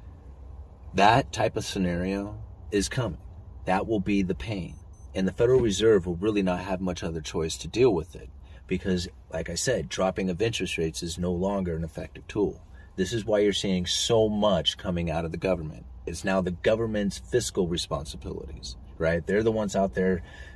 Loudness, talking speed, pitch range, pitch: -27 LUFS, 185 wpm, 85-100 Hz, 90 Hz